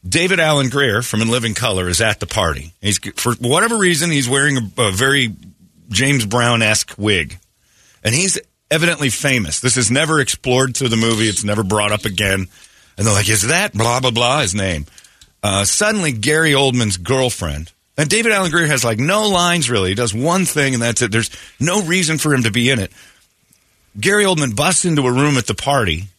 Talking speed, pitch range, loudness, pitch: 205 wpm, 105-145 Hz, -15 LUFS, 120 Hz